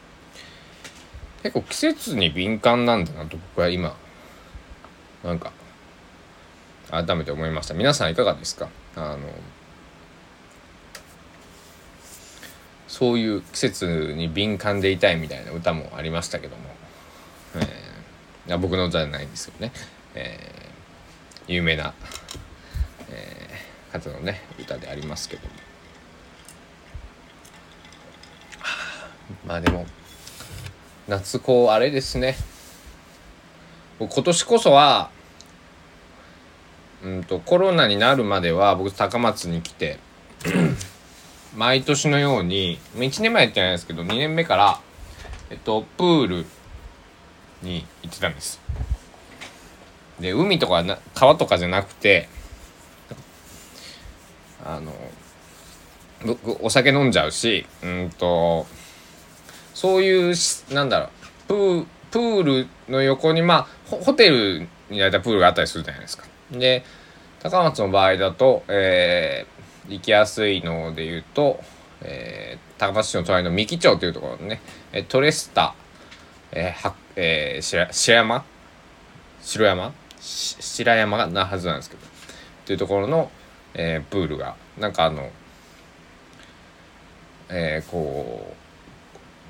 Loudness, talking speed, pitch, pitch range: -21 LUFS, 220 characters per minute, 85 Hz, 80-100 Hz